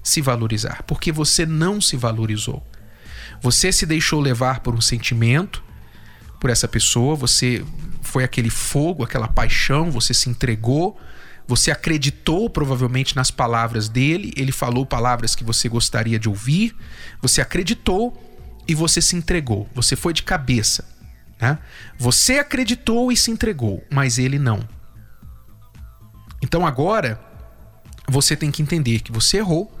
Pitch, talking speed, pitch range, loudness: 130 Hz, 135 wpm, 115-160 Hz, -19 LUFS